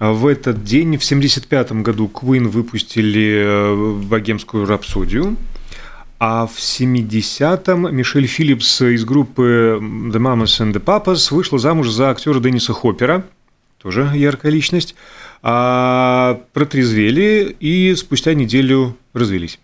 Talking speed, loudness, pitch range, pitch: 115 wpm, -15 LUFS, 110-145 Hz, 125 Hz